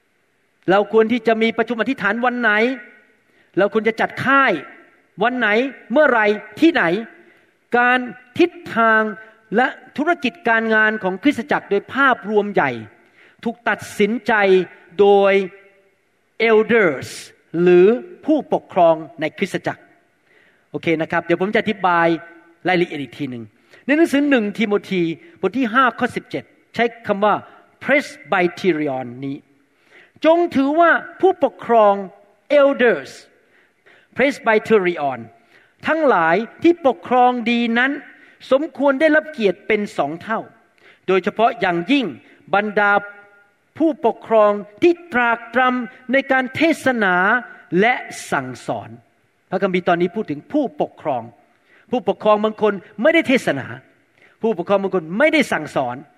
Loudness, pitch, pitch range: -18 LUFS, 220 Hz, 190-255 Hz